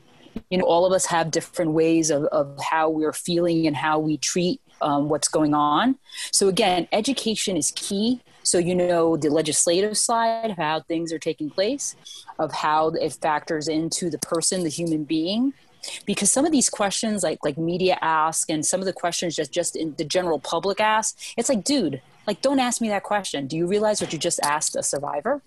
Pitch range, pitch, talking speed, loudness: 160-210 Hz, 175 Hz, 205 wpm, -22 LUFS